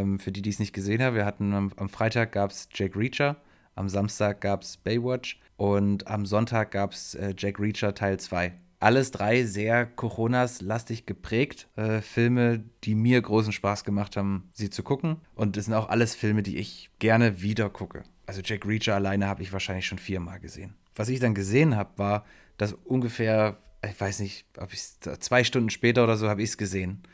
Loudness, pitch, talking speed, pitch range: -27 LUFS, 105 Hz, 200 wpm, 100-115 Hz